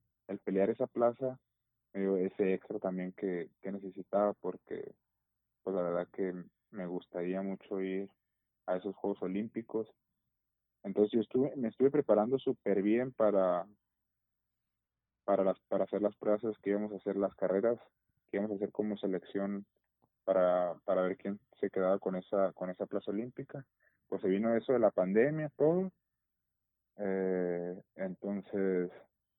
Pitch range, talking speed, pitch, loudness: 95-110 Hz, 145 wpm, 100 Hz, -34 LUFS